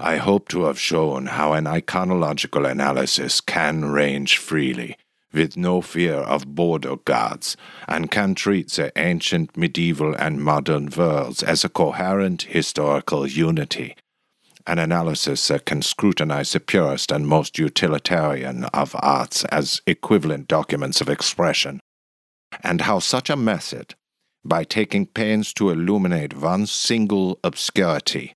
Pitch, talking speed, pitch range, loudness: 80 Hz, 130 wpm, 75-95 Hz, -21 LUFS